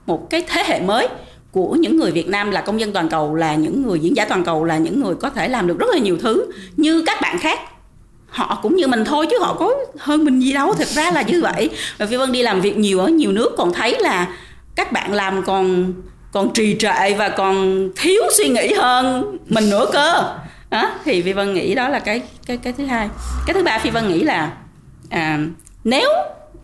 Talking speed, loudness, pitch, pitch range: 235 wpm, -17 LUFS, 215 Hz, 190-290 Hz